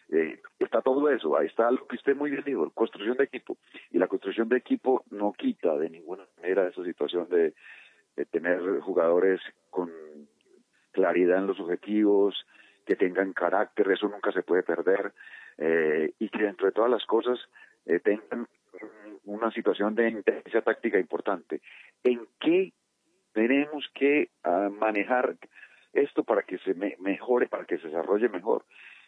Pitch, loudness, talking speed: 125 Hz, -27 LUFS, 155 wpm